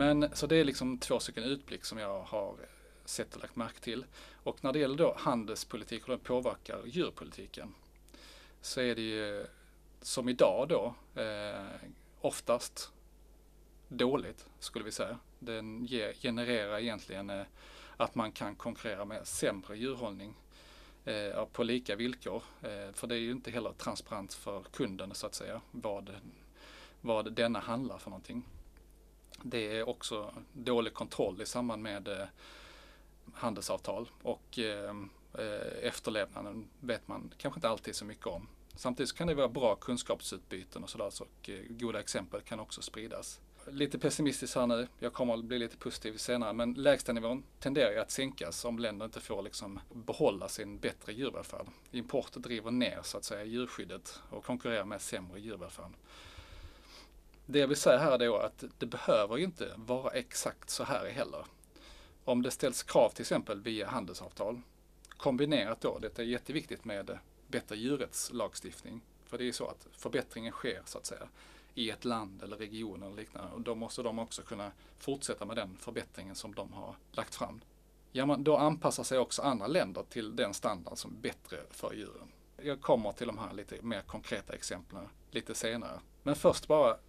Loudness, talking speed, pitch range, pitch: -36 LUFS, 165 wpm, 105-125 Hz, 115 Hz